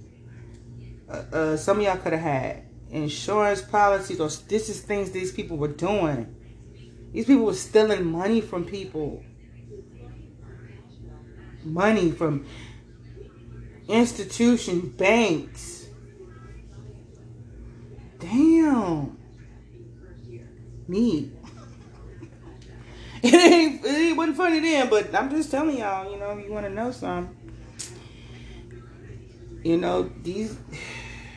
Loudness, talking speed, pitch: -23 LUFS, 100 wpm, 145 Hz